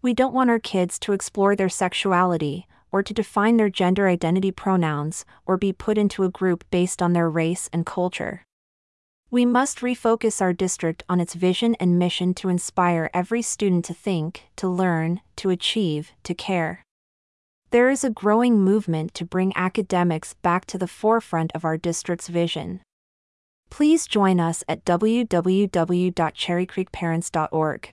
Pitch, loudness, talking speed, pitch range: 180 Hz, -22 LUFS, 155 wpm, 170-200 Hz